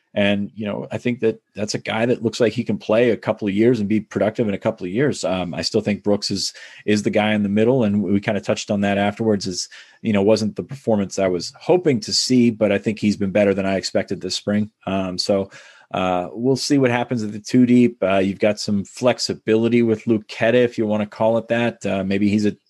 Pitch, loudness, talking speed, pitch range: 105 Hz, -20 LUFS, 260 wpm, 100-115 Hz